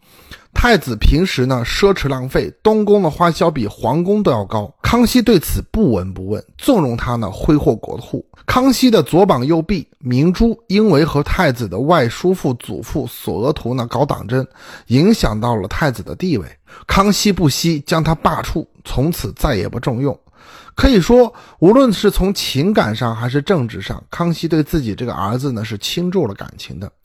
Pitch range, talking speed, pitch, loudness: 120-195 Hz, 265 characters per minute, 155 Hz, -16 LUFS